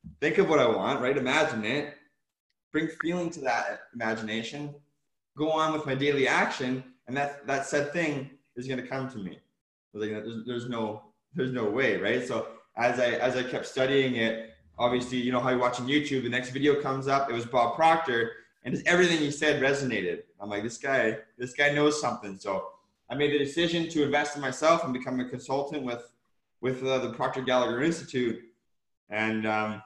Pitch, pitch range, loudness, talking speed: 130 Hz, 120-145 Hz, -28 LUFS, 200 wpm